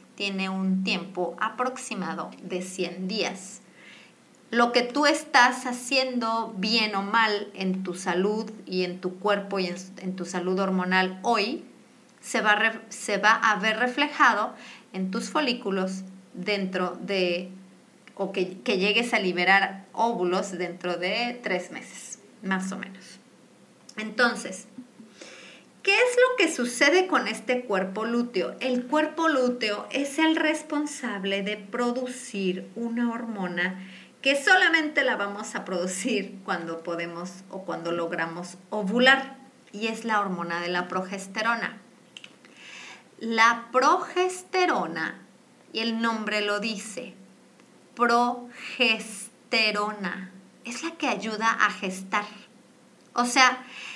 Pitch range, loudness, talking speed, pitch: 190-245 Hz, -25 LUFS, 120 wpm, 215 Hz